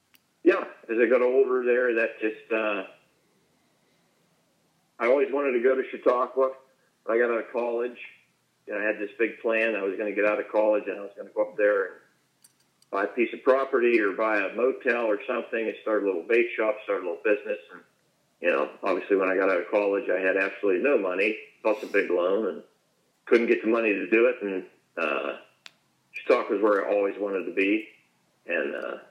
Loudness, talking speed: -26 LUFS, 215 wpm